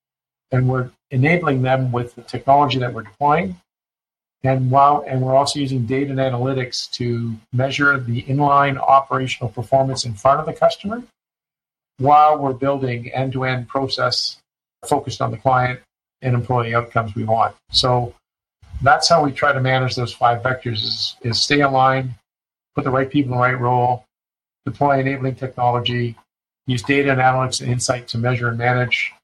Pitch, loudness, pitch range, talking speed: 130 Hz, -18 LUFS, 125-140 Hz, 160 wpm